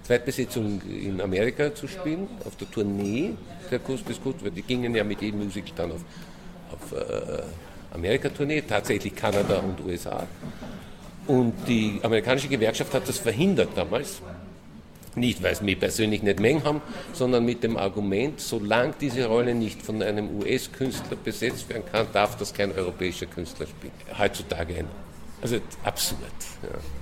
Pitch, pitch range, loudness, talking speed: 110 Hz, 100-130 Hz, -27 LUFS, 150 wpm